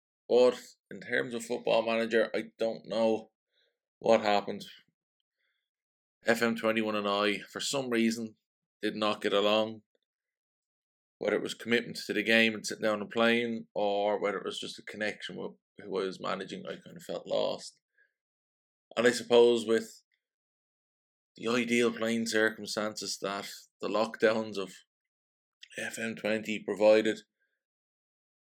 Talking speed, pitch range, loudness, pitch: 135 wpm, 105-115 Hz, -30 LUFS, 110 Hz